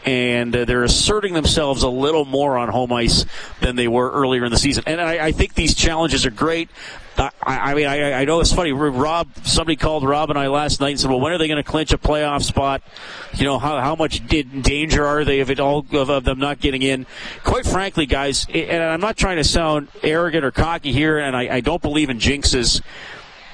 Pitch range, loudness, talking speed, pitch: 135-155 Hz, -18 LUFS, 230 wpm, 145 Hz